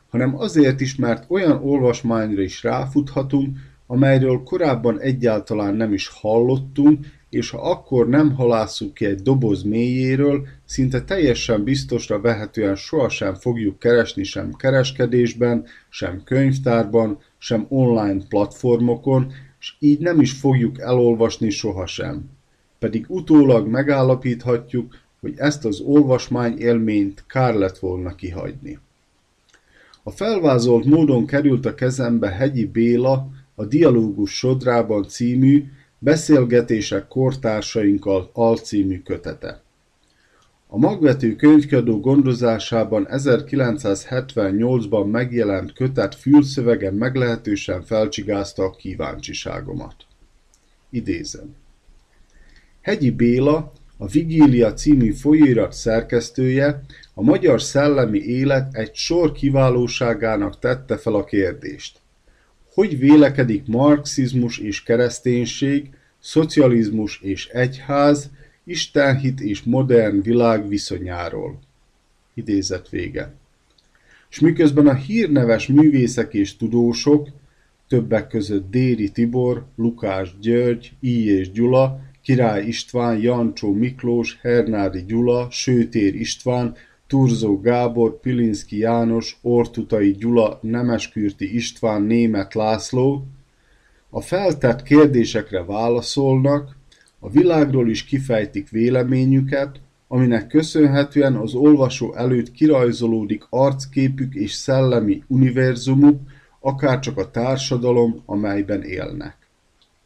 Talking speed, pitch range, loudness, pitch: 95 wpm, 110-135 Hz, -18 LUFS, 120 Hz